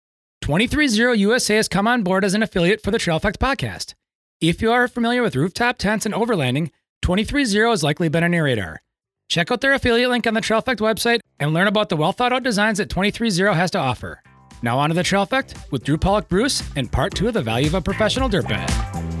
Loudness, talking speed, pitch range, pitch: -19 LUFS, 240 wpm, 155-230 Hz, 200 Hz